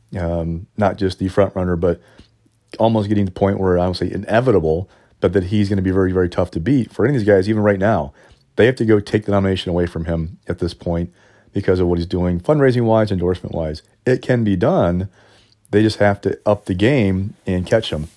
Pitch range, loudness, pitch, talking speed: 90-105 Hz, -18 LUFS, 100 Hz, 240 wpm